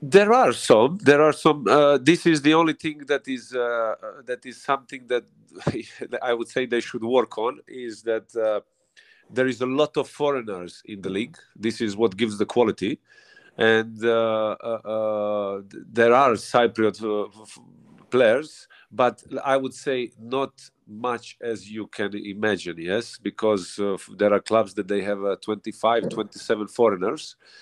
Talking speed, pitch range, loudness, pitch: 175 wpm, 105-135 Hz, -23 LUFS, 115 Hz